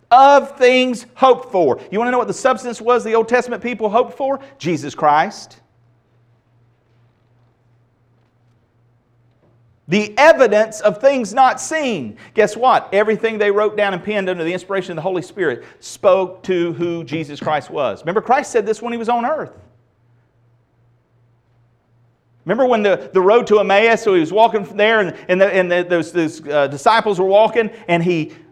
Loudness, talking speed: -16 LUFS, 175 wpm